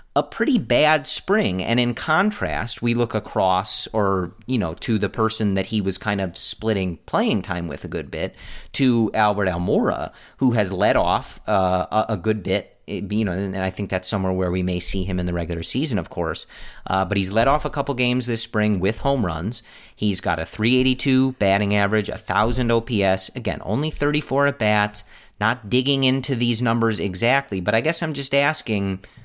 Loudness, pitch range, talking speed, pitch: -22 LUFS, 95-120 Hz, 195 wpm, 105 Hz